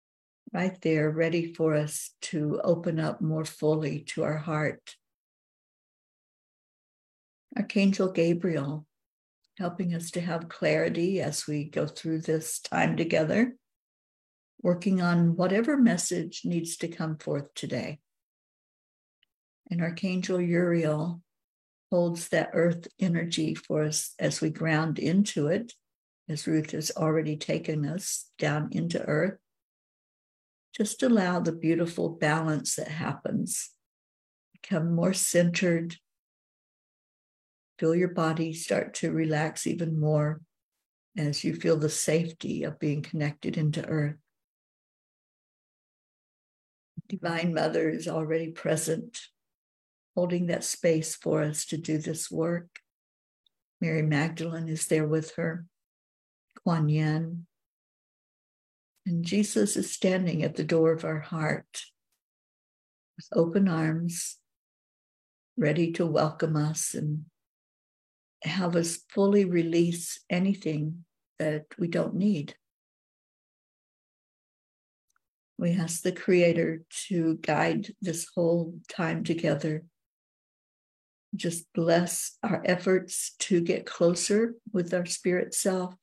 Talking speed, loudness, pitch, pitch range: 110 wpm, -28 LUFS, 165 Hz, 155-180 Hz